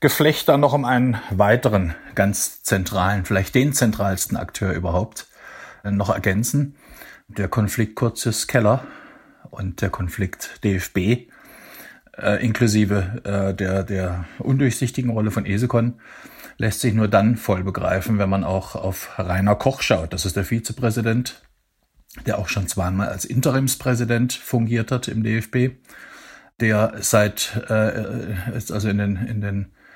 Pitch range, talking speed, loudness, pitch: 100-120 Hz, 135 wpm, -21 LUFS, 110 Hz